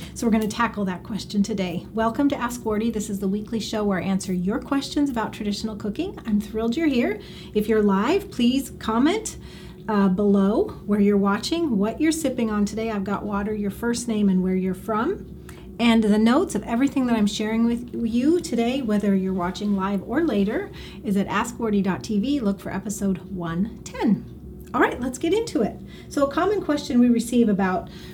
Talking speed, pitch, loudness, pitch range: 195 wpm, 215 Hz, -23 LUFS, 200-240 Hz